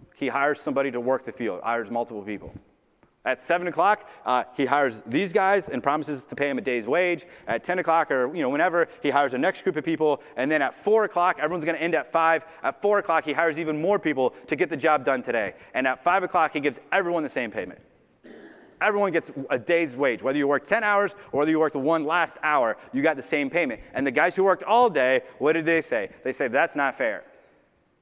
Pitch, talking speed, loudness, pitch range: 160 Hz, 240 wpm, -24 LUFS, 140-180 Hz